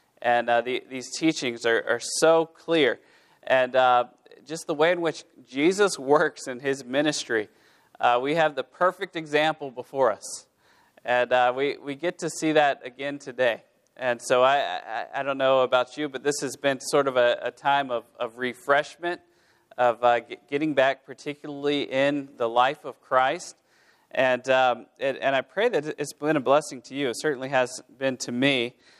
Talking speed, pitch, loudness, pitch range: 185 wpm, 140 Hz, -25 LUFS, 125-150 Hz